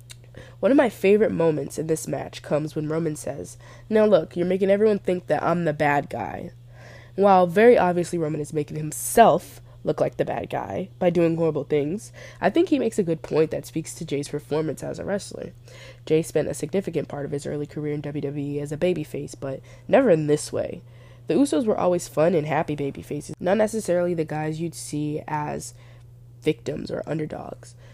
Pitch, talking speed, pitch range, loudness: 150 Hz, 195 wpm, 135-170 Hz, -23 LUFS